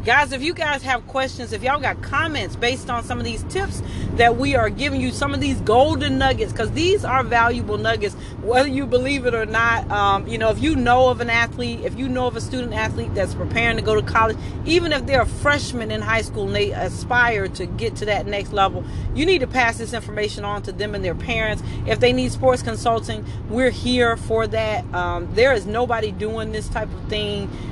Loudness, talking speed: -20 LUFS, 230 wpm